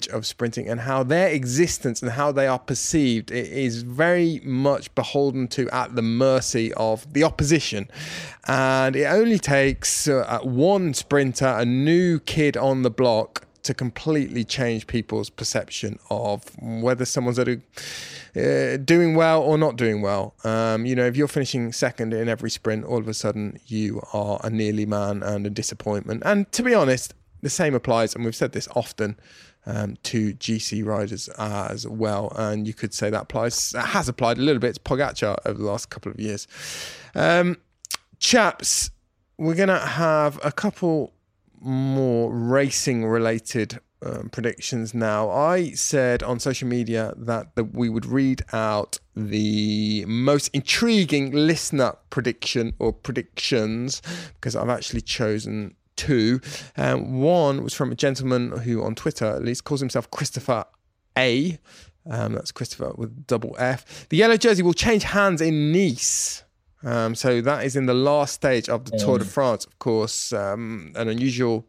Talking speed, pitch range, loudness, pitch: 160 wpm, 110-145 Hz, -23 LUFS, 125 Hz